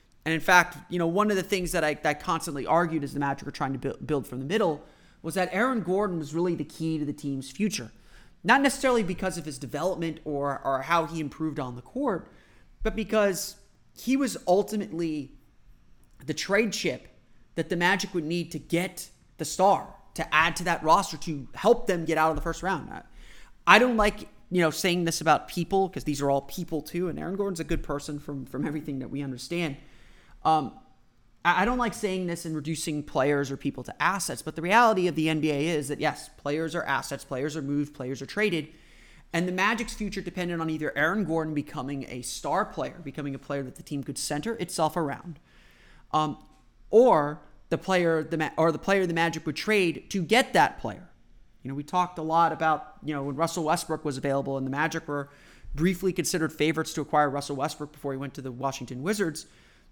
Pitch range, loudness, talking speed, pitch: 145-180 Hz, -27 LUFS, 210 wpm, 160 Hz